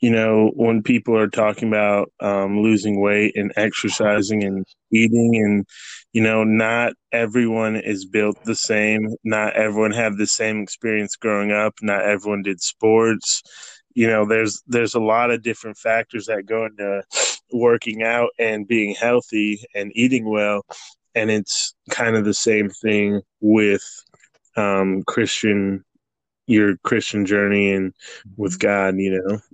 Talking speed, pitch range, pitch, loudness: 150 wpm, 100-115 Hz, 105 Hz, -19 LUFS